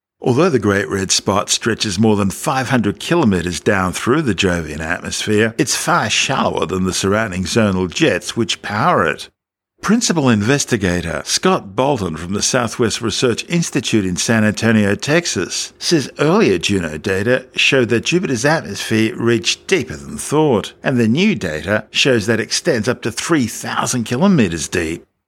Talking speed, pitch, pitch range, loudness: 150 wpm, 110 Hz, 95-130 Hz, -16 LUFS